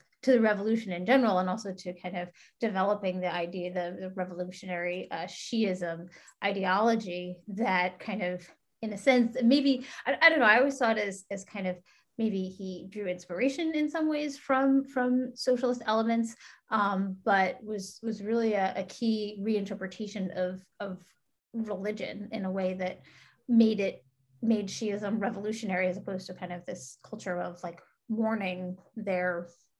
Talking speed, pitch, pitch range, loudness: 165 wpm, 200 Hz, 180-225 Hz, -30 LUFS